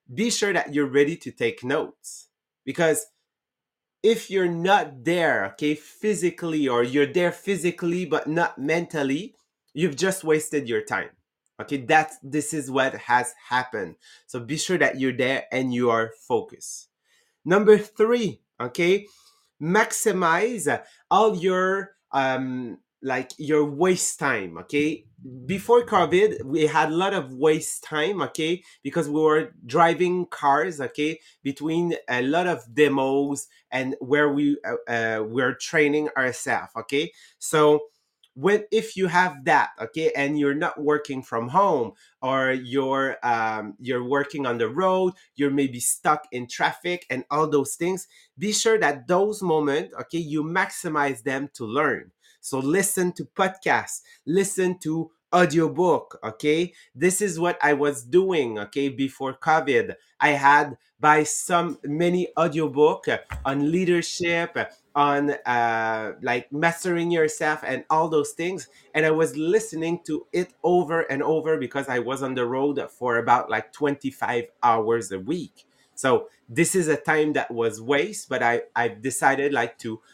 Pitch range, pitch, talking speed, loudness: 135-175 Hz, 150 Hz, 150 wpm, -23 LUFS